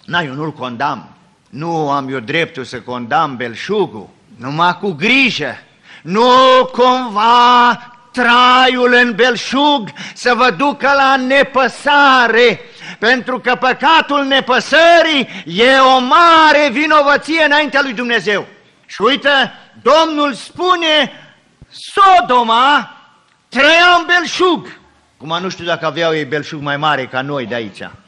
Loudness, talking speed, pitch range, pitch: -12 LUFS, 120 wpm, 170-285 Hz, 245 Hz